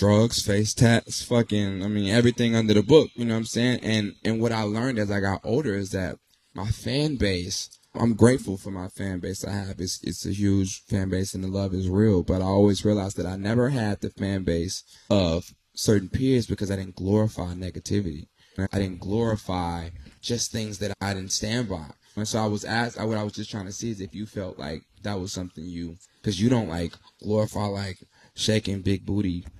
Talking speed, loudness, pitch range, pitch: 215 wpm, -25 LUFS, 95-110 Hz, 100 Hz